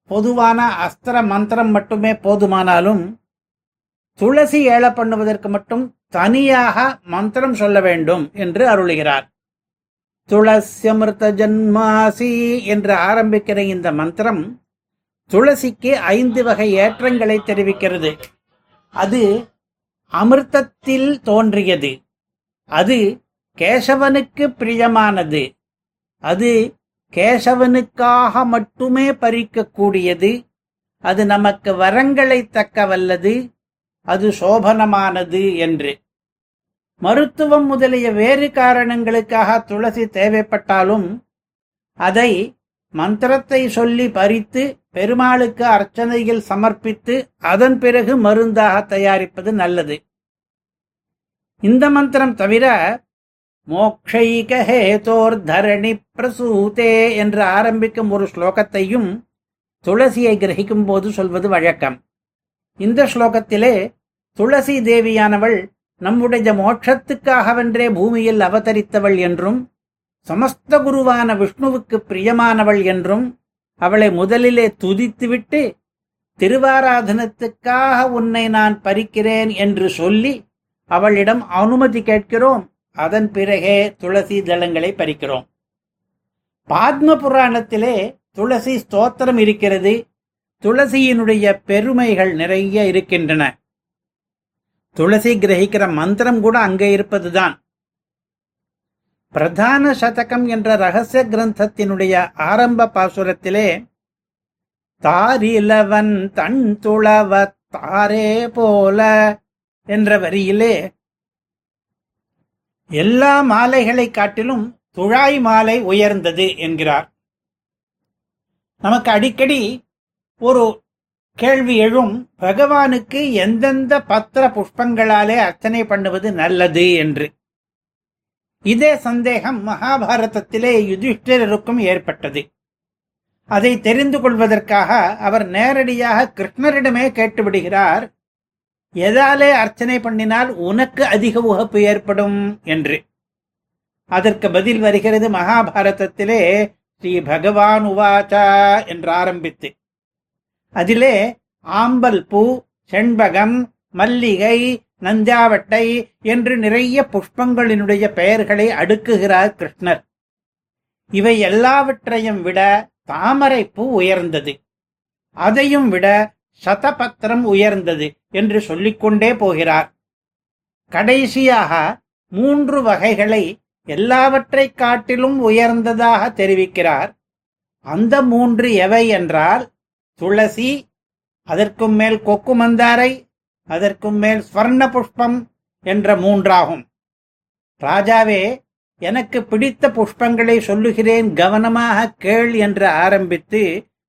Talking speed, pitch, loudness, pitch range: 75 wpm, 220 Hz, -14 LUFS, 200-240 Hz